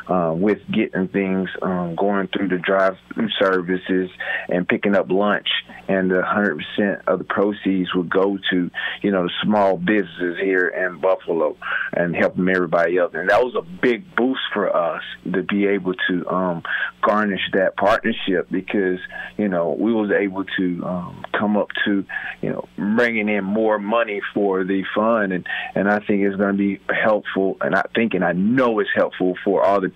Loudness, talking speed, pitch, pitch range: -20 LUFS, 180 wpm, 95 Hz, 90-100 Hz